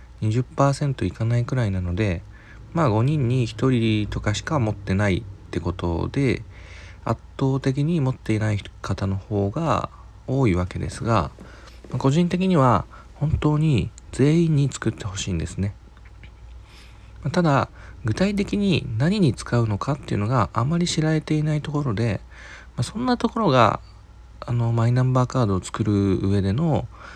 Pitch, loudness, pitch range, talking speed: 115 Hz, -23 LUFS, 100-140 Hz, 280 characters per minute